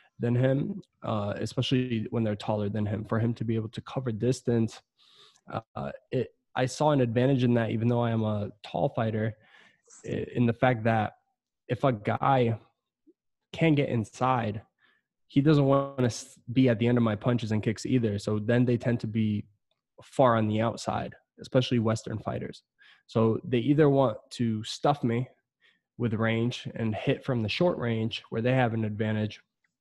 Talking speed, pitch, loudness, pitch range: 180 wpm, 120 Hz, -28 LUFS, 110-130 Hz